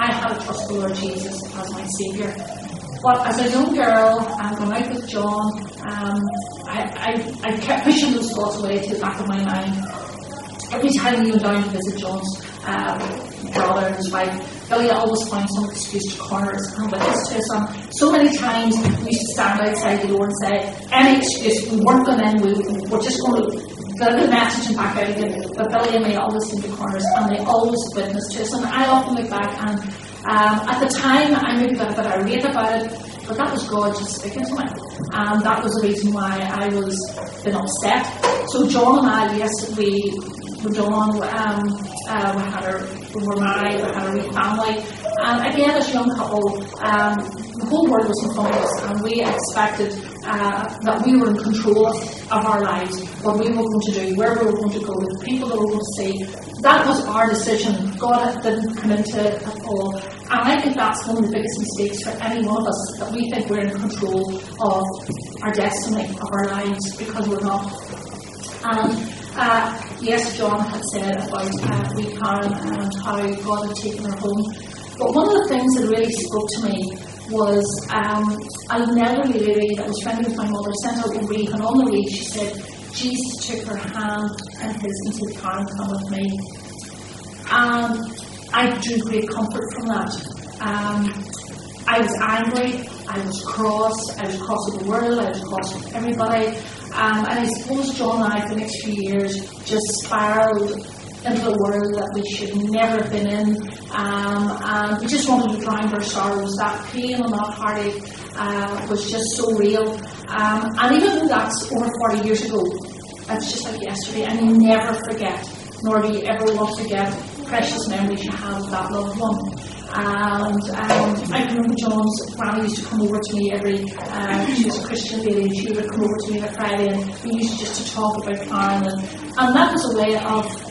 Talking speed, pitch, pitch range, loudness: 205 wpm, 215 Hz, 205-225 Hz, -20 LUFS